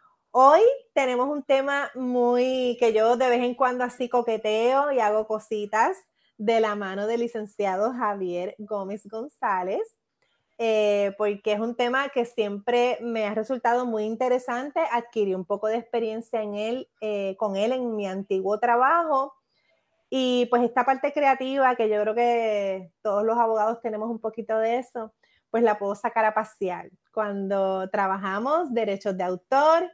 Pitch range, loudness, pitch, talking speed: 210-250 Hz, -25 LUFS, 230 Hz, 155 wpm